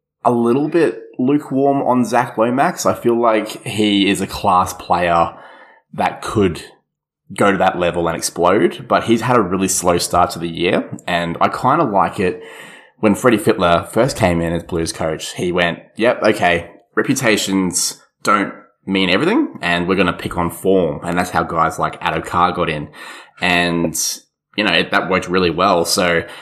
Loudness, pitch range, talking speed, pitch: -16 LUFS, 85-110 Hz, 180 wpm, 90 Hz